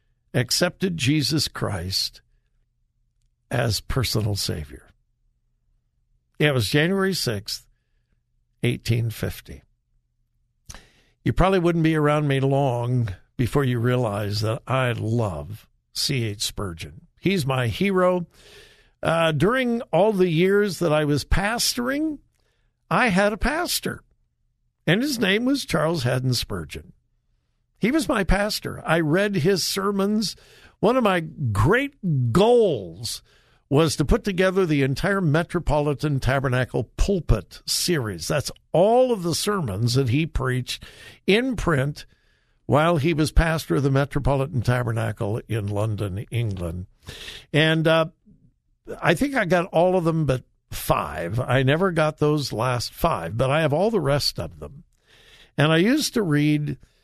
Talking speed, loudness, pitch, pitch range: 130 wpm, -22 LUFS, 145 Hz, 120-180 Hz